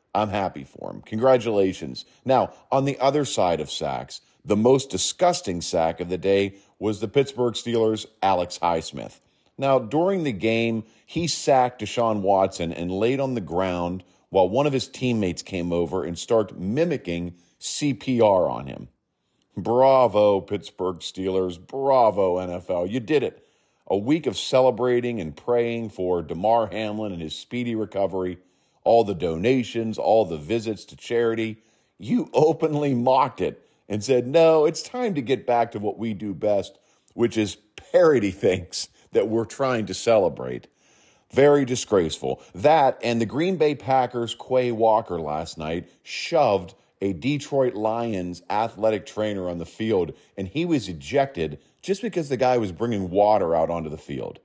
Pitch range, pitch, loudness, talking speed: 95-130 Hz, 110 Hz, -23 LUFS, 155 wpm